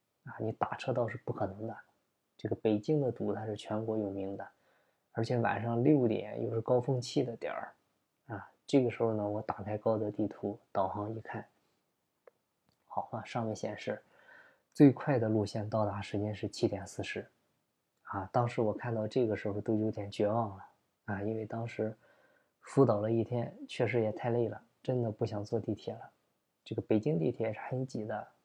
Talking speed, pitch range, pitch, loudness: 265 characters per minute, 105-120 Hz, 110 Hz, -34 LUFS